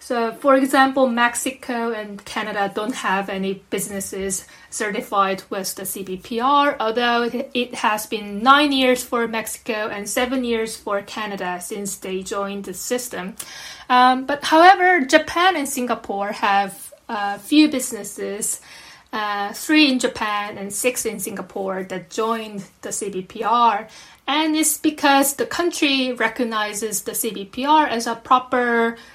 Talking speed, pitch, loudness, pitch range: 135 wpm, 230 Hz, -20 LUFS, 200-260 Hz